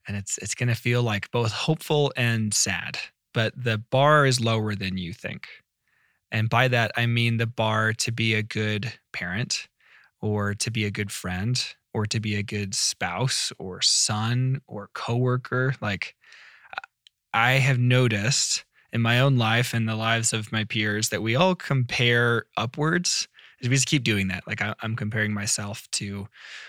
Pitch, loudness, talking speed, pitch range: 115 Hz, -24 LUFS, 170 wpm, 105-125 Hz